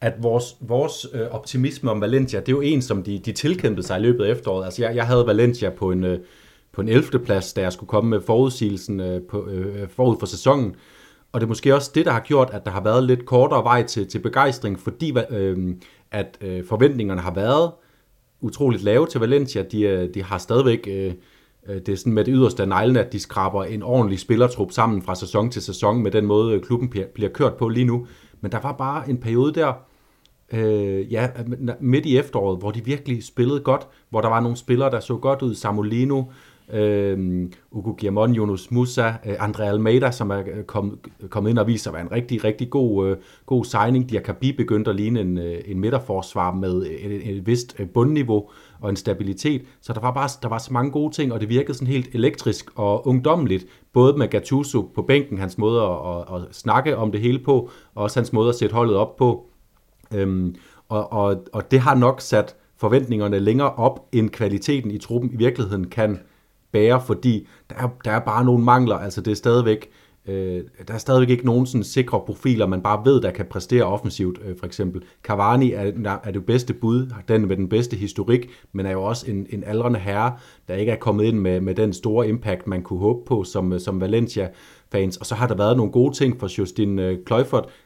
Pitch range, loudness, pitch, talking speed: 100-125 Hz, -21 LUFS, 110 Hz, 210 wpm